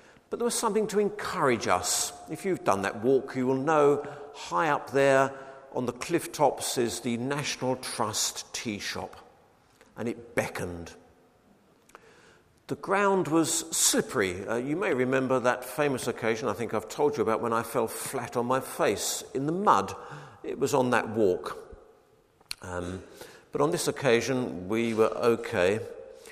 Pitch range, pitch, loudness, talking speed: 120-165 Hz, 135 Hz, -28 LUFS, 160 wpm